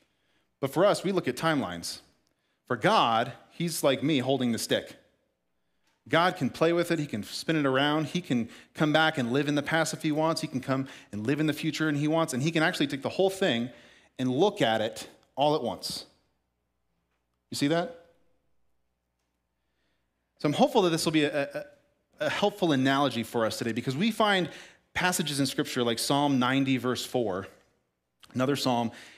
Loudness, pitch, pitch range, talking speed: -27 LUFS, 135 Hz, 110-160 Hz, 195 wpm